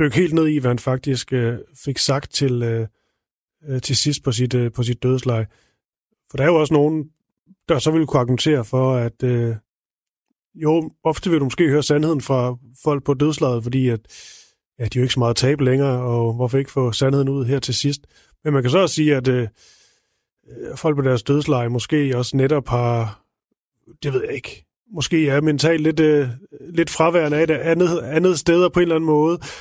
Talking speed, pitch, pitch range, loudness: 205 wpm, 140 Hz, 125-155 Hz, -19 LUFS